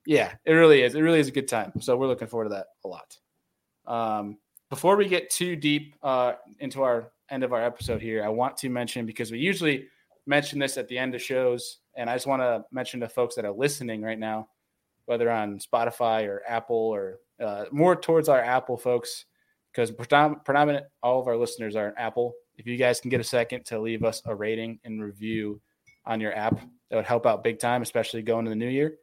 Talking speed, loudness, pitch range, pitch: 225 wpm, -26 LUFS, 110-135 Hz, 120 Hz